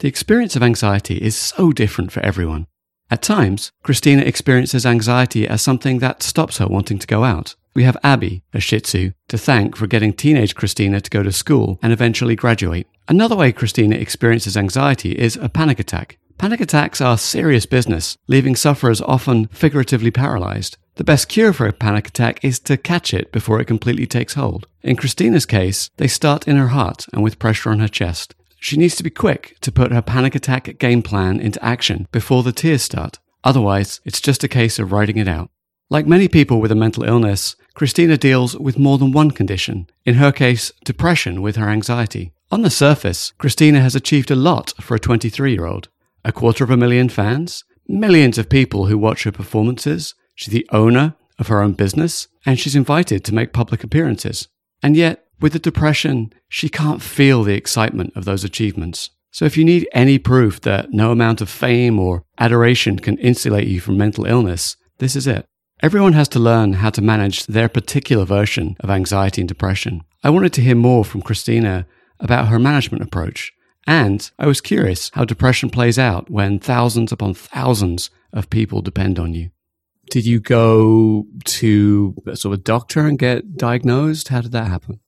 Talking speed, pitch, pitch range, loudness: 190 wpm, 115 Hz, 105-135 Hz, -16 LUFS